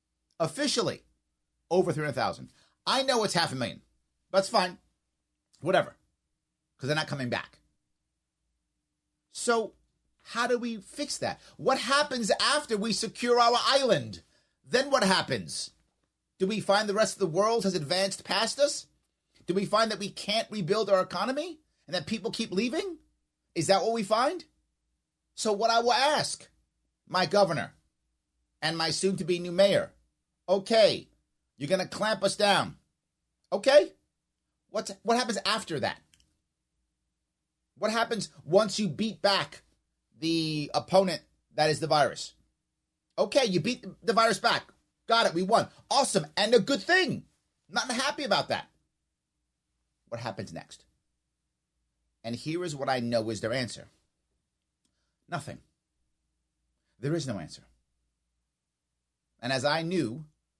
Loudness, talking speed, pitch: -28 LUFS, 140 wpm, 170 Hz